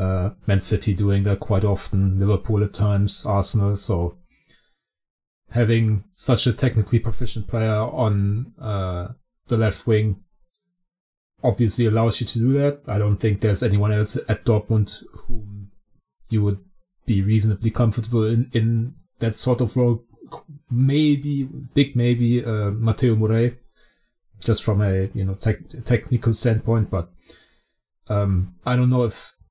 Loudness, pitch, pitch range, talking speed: -21 LUFS, 110 Hz, 100-120 Hz, 140 wpm